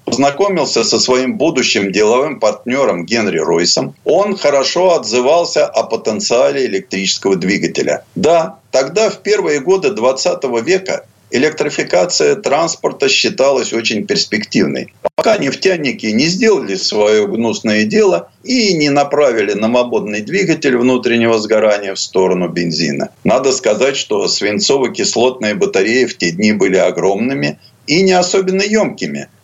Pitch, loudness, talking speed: 130 Hz, -13 LUFS, 120 wpm